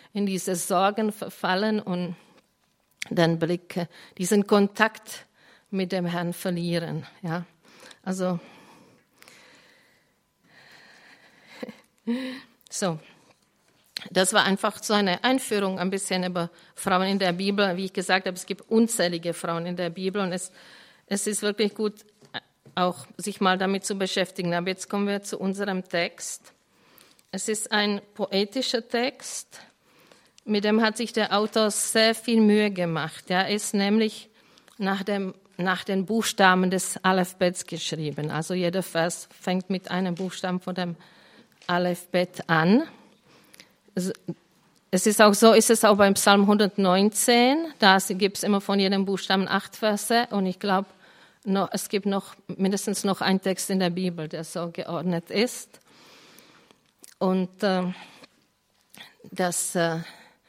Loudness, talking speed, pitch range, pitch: -25 LUFS, 135 wpm, 180-210 Hz, 190 Hz